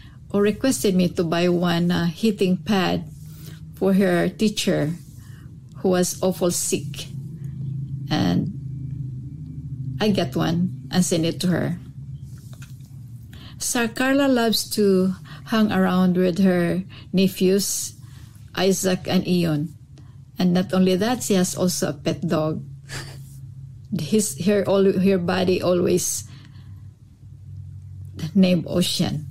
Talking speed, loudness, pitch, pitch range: 115 wpm, -21 LUFS, 165 Hz, 135-185 Hz